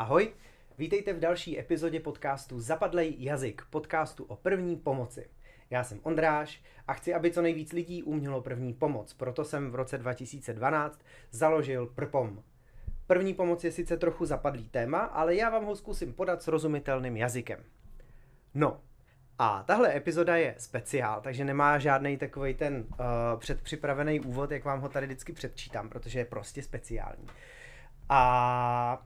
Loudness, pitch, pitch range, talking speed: -31 LUFS, 140 Hz, 125-155 Hz, 150 wpm